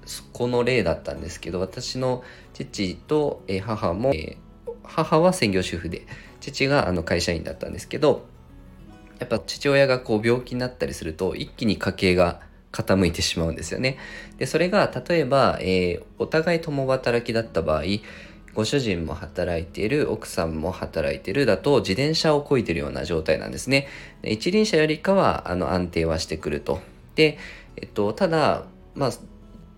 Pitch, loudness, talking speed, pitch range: 105 Hz, -24 LUFS, 320 characters per minute, 85-135 Hz